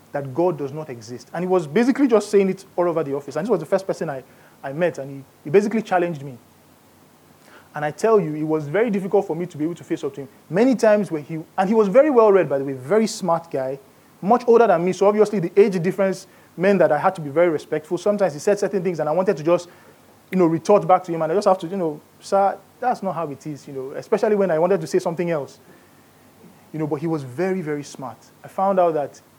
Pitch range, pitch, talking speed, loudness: 150-200 Hz, 175 Hz, 270 wpm, -20 LUFS